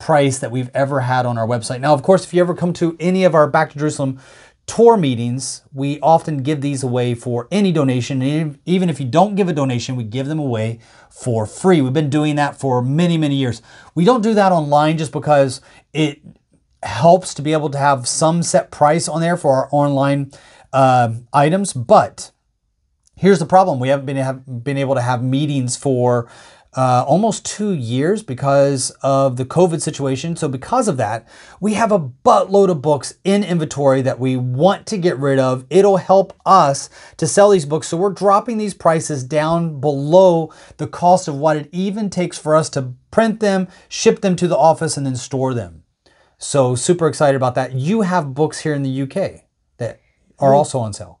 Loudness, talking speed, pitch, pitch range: -16 LUFS, 200 wpm, 150 Hz, 135-175 Hz